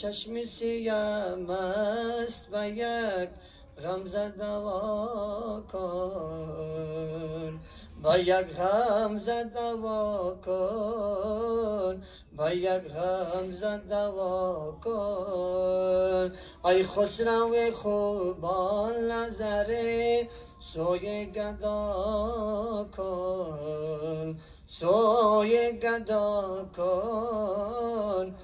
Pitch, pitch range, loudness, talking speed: 205 Hz, 185-220 Hz, -30 LUFS, 45 wpm